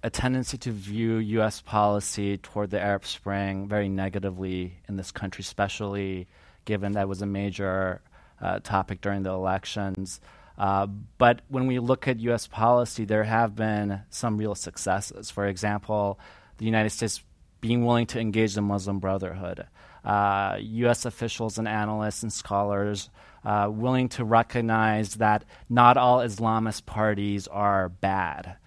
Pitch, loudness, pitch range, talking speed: 105 Hz, -26 LUFS, 95-110 Hz, 145 wpm